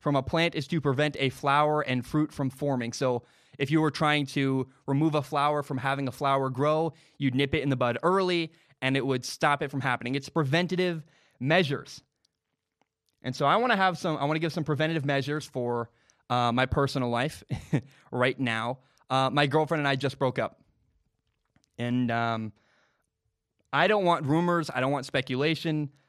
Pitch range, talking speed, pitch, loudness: 130-155 Hz, 190 wpm, 140 Hz, -27 LUFS